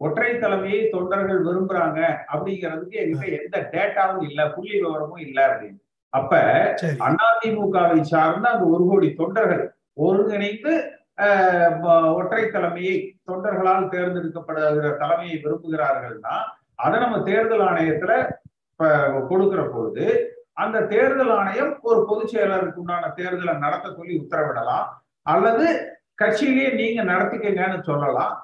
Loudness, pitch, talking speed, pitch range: -21 LUFS, 190 Hz, 105 wpm, 165-225 Hz